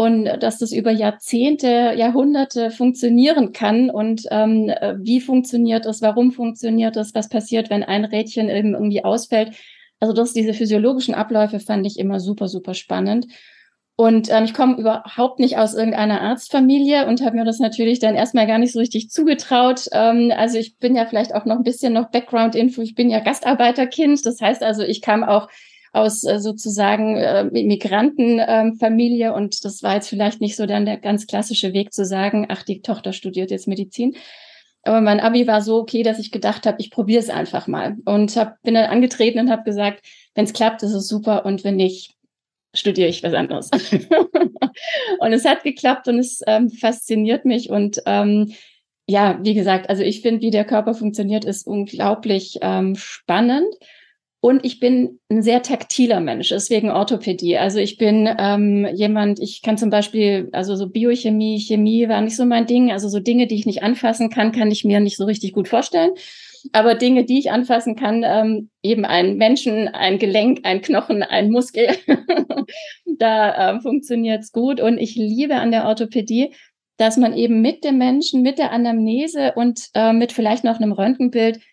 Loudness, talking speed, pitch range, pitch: -18 LUFS, 185 wpm, 210-245 Hz, 225 Hz